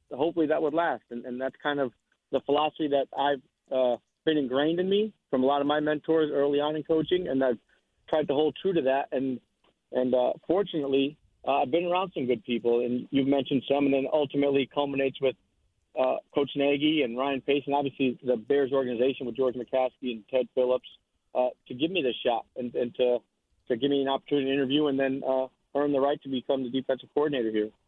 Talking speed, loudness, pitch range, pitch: 215 wpm, -28 LUFS, 125-145 Hz, 135 Hz